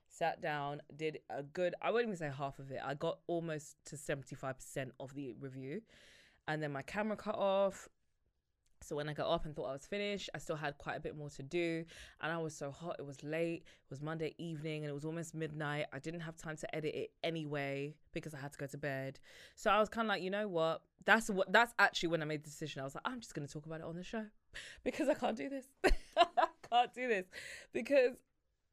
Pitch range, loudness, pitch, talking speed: 145-195 Hz, -39 LUFS, 160 Hz, 245 wpm